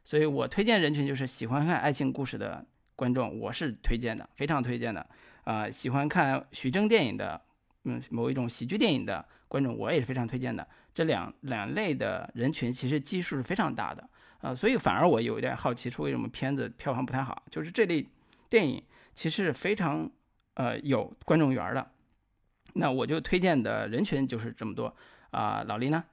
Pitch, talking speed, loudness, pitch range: 135 Hz, 300 characters per minute, -30 LUFS, 120-145 Hz